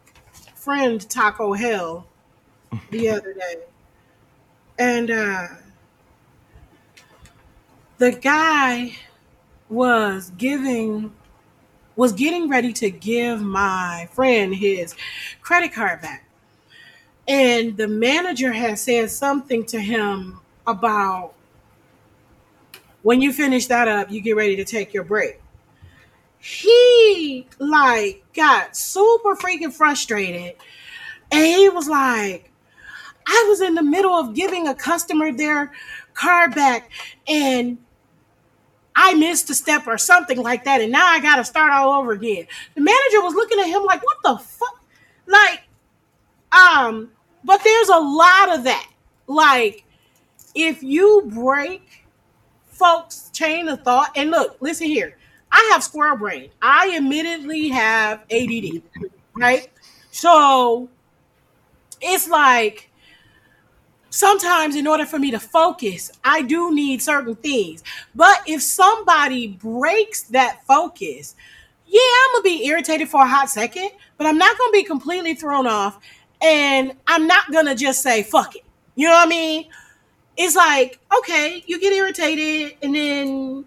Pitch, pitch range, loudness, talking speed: 285 Hz, 230-345 Hz, -17 LUFS, 135 wpm